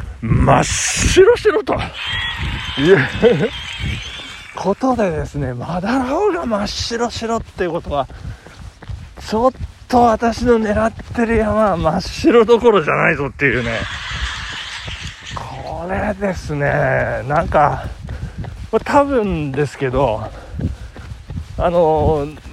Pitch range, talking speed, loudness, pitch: 150-240 Hz, 195 characters per minute, -17 LUFS, 215 Hz